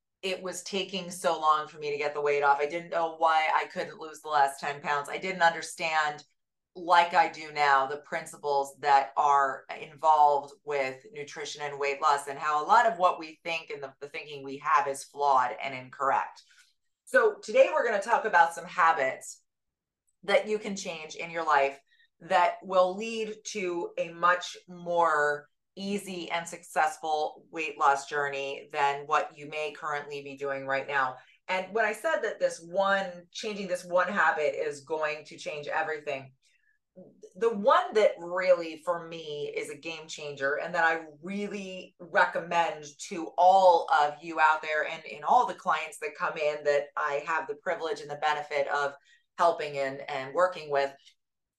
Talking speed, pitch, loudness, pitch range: 180 wpm, 160 Hz, -28 LUFS, 145-180 Hz